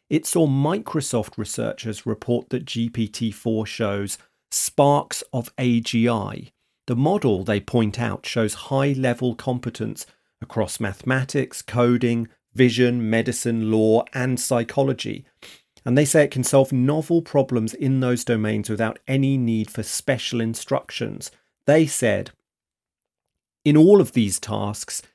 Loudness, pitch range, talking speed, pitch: -22 LUFS, 110-135 Hz, 125 wpm, 120 Hz